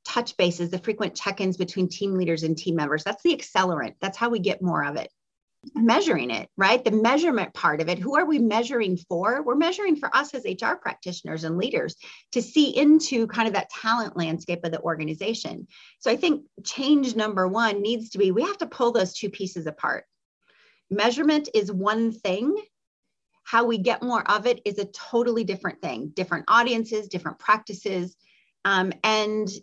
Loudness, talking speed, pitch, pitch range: -24 LUFS, 190 wpm, 215 Hz, 185-240 Hz